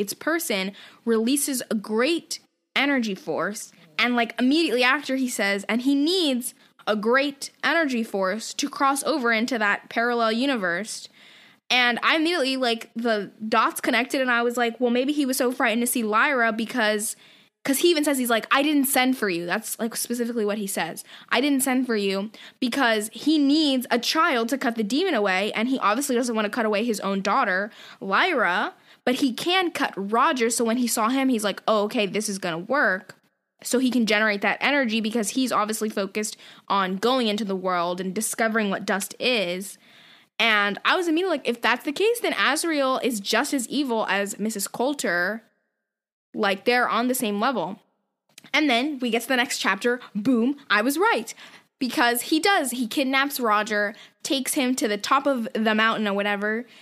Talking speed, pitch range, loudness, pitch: 190 wpm, 210-270 Hz, -23 LUFS, 235 Hz